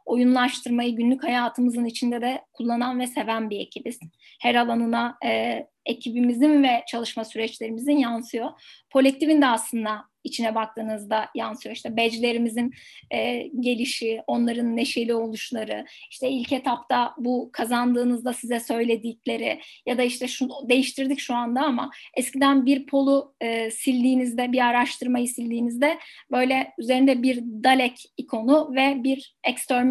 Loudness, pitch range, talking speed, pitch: -24 LUFS, 235-260 Hz, 125 wpm, 245 Hz